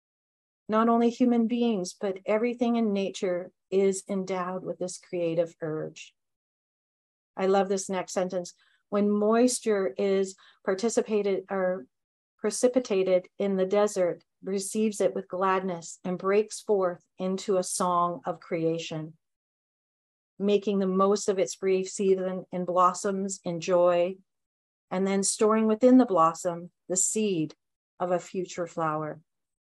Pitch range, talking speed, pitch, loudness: 180-205 Hz, 130 wpm, 190 Hz, -27 LUFS